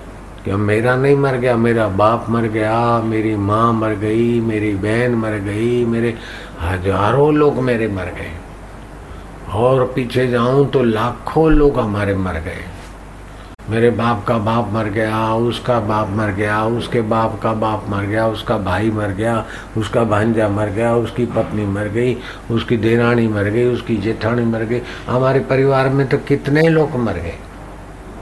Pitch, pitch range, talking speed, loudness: 115 Hz, 105-120 Hz, 160 wpm, -17 LUFS